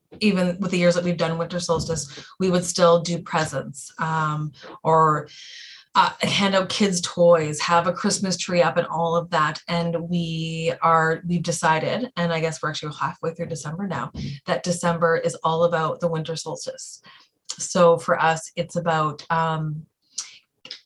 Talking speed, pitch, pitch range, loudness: 165 wpm, 170 Hz, 160-175 Hz, -22 LUFS